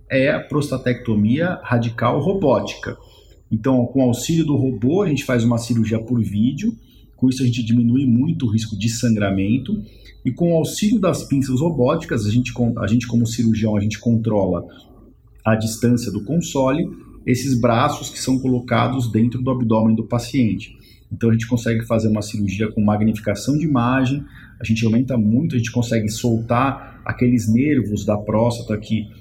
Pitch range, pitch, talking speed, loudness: 110-130 Hz, 120 Hz, 170 wpm, -19 LUFS